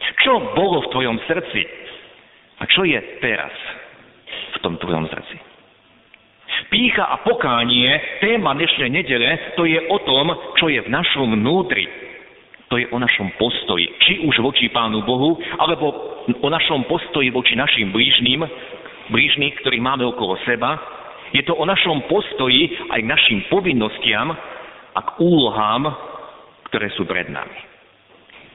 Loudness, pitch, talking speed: -17 LUFS, 165 Hz, 140 wpm